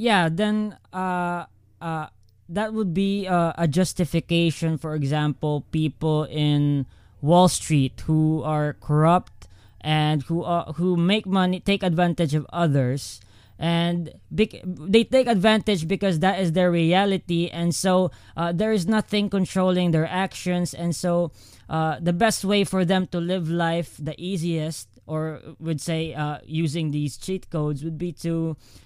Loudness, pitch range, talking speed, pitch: -23 LUFS, 155-185 Hz, 150 wpm, 170 Hz